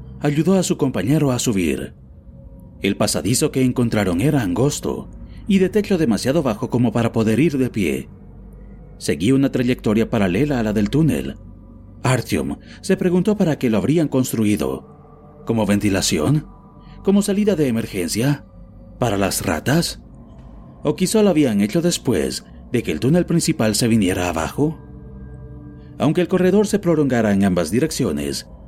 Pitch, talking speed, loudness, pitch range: 120 Hz, 145 wpm, -19 LUFS, 100-155 Hz